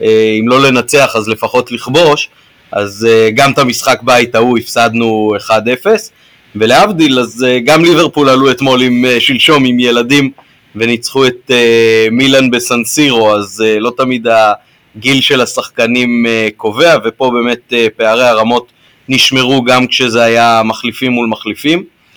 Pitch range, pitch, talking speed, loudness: 115-130 Hz, 120 Hz, 125 wpm, -9 LUFS